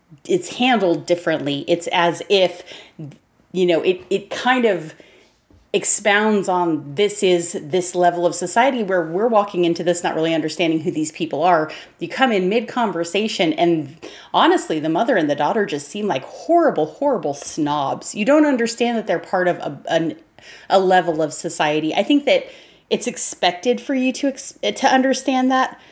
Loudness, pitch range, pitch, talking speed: -19 LUFS, 170-235 Hz, 185 Hz, 170 wpm